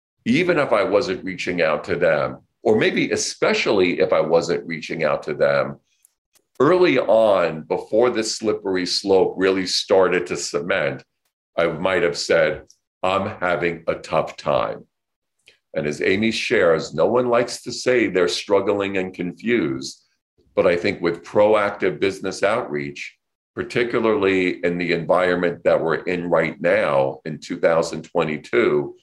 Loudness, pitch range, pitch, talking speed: -20 LUFS, 85-105 Hz, 95 Hz, 140 wpm